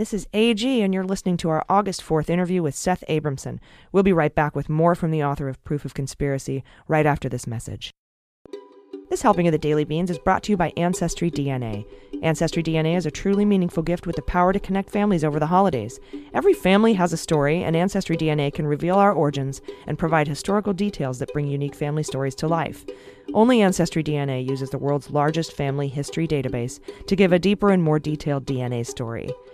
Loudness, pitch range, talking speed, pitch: -22 LUFS, 140-180 Hz, 205 wpm, 155 Hz